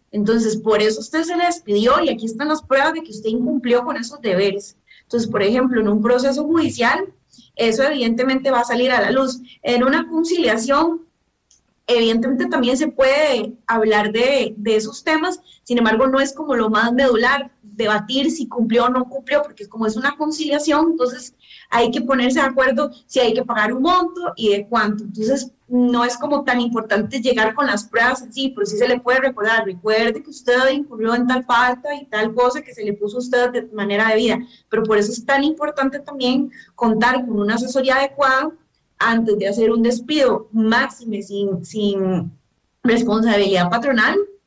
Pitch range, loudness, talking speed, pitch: 220-275 Hz, -18 LUFS, 190 wpm, 245 Hz